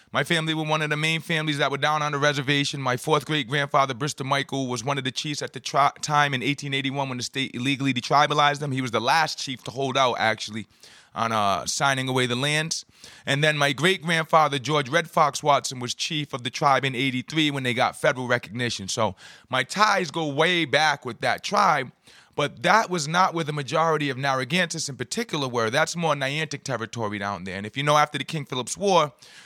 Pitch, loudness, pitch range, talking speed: 140 Hz, -24 LUFS, 130-155 Hz, 220 wpm